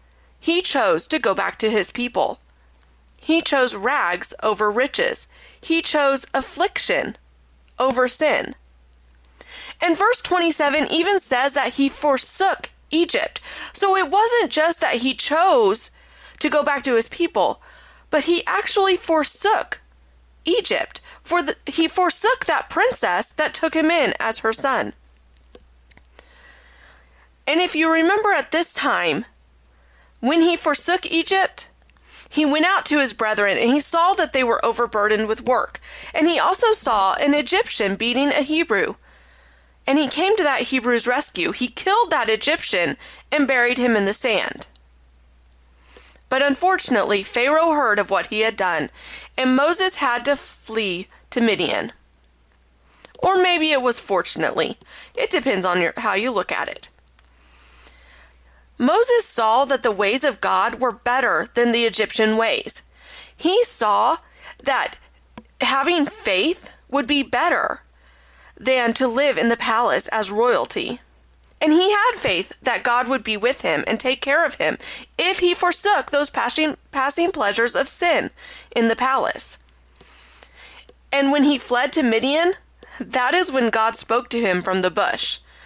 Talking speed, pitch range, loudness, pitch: 150 wpm, 215-330 Hz, -19 LUFS, 270 Hz